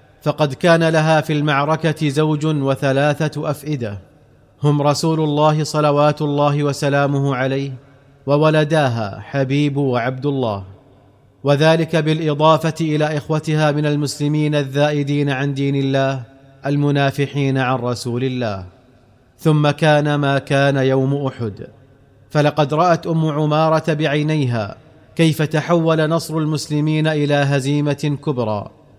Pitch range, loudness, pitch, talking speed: 135-155 Hz, -17 LUFS, 145 Hz, 105 wpm